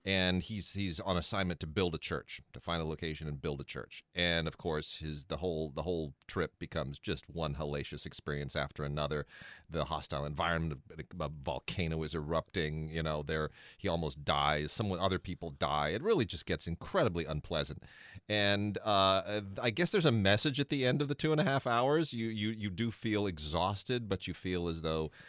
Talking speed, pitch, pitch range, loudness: 200 wpm, 85 Hz, 80-100 Hz, -35 LUFS